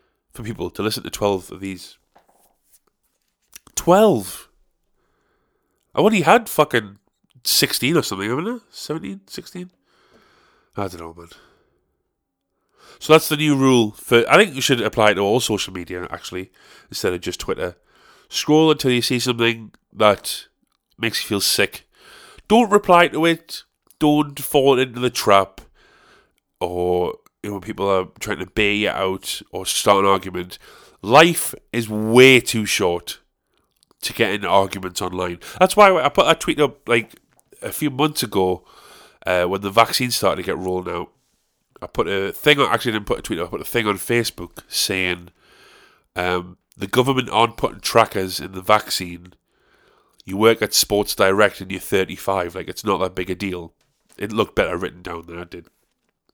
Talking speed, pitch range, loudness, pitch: 175 wpm, 95-130 Hz, -19 LUFS, 105 Hz